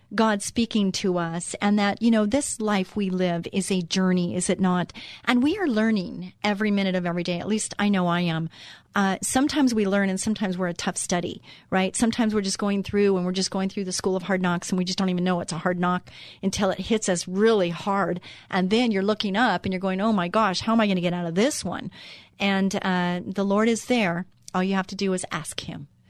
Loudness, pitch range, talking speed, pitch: -24 LUFS, 180-210 Hz, 255 wpm, 195 Hz